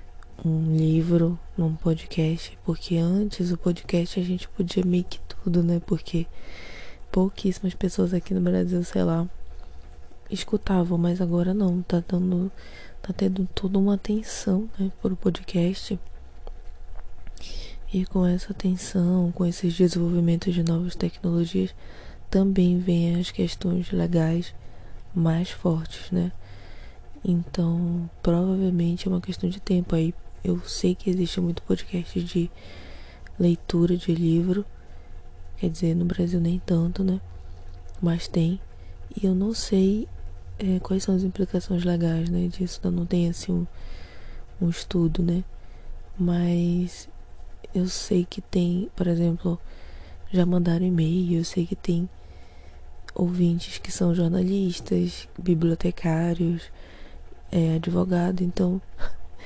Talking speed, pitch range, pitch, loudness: 125 wpm, 160-185 Hz, 175 Hz, -25 LUFS